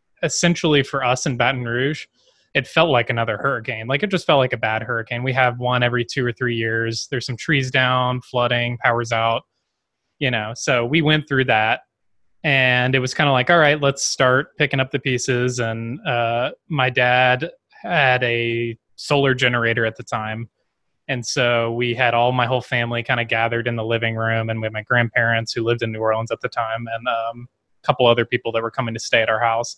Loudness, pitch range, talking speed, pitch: -19 LUFS, 115-135 Hz, 220 wpm, 125 Hz